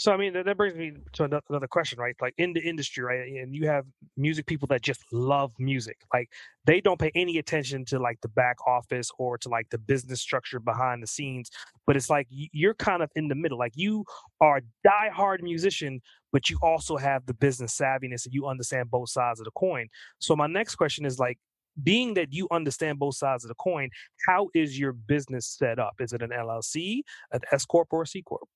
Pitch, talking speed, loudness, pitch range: 140 Hz, 225 wpm, -28 LUFS, 125-165 Hz